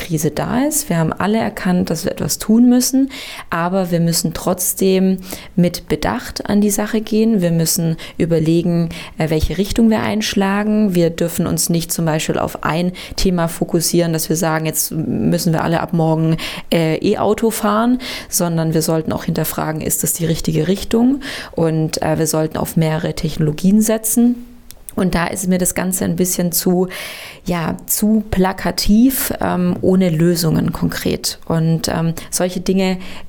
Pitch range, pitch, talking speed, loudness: 165-210 Hz, 180 Hz, 160 wpm, -17 LUFS